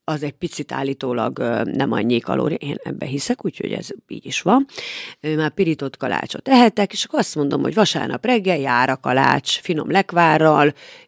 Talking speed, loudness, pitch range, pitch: 170 wpm, -19 LUFS, 145-235 Hz, 165 Hz